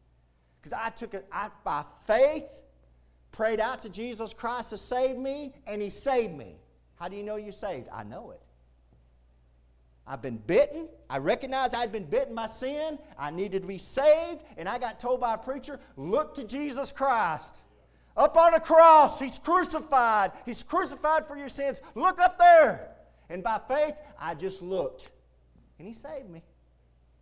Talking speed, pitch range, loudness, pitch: 170 wpm, 170-285 Hz, -26 LUFS, 235 Hz